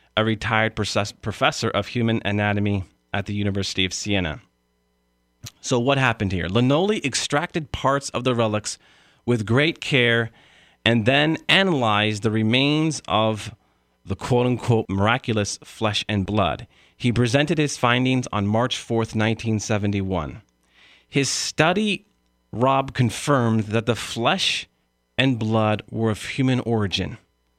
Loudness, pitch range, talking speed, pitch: -22 LUFS, 100-130 Hz, 130 wpm, 110 Hz